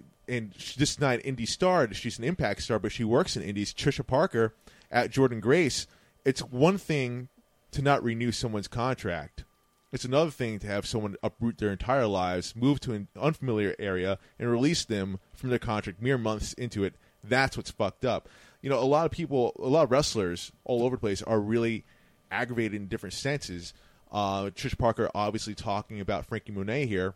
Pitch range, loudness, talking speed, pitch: 100-130 Hz, -29 LUFS, 190 wpm, 115 Hz